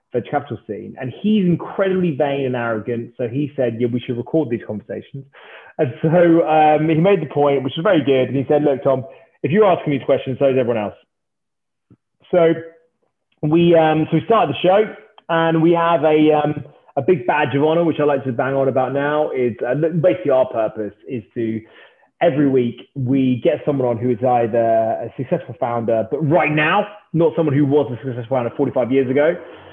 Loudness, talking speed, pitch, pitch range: -18 LUFS, 200 wpm, 145 Hz, 125-165 Hz